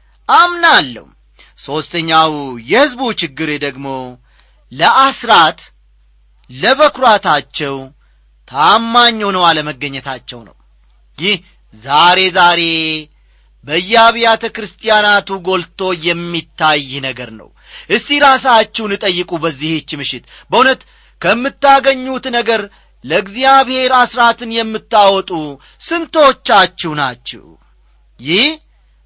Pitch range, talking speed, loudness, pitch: 145-235 Hz, 70 wpm, -12 LUFS, 180 Hz